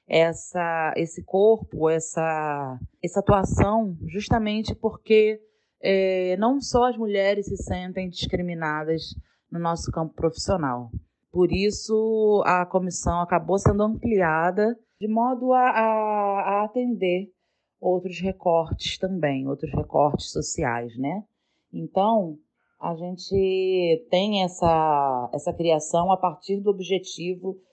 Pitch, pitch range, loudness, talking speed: 185 Hz, 165-205 Hz, -24 LUFS, 110 wpm